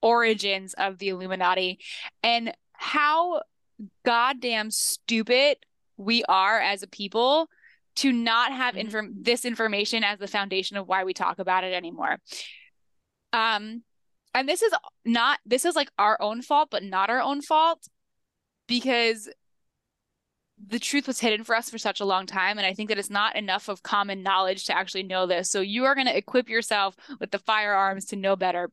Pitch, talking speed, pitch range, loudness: 215 Hz, 175 wpm, 195-245 Hz, -25 LUFS